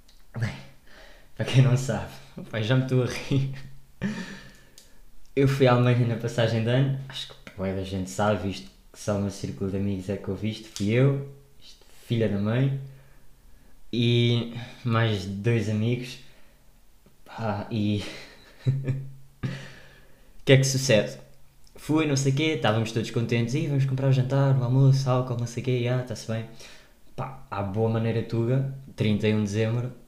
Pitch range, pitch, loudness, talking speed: 105-135 Hz, 120 Hz, -26 LUFS, 160 wpm